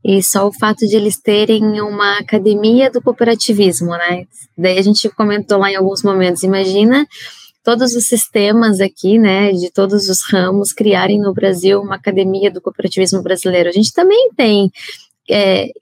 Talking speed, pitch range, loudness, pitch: 165 wpm, 190-220 Hz, -13 LUFS, 200 Hz